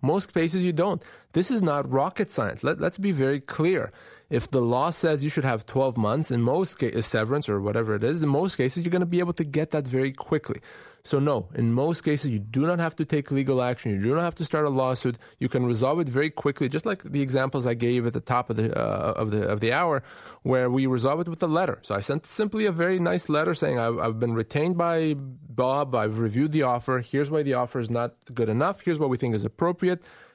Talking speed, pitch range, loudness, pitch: 260 wpm, 125-160 Hz, -26 LUFS, 135 Hz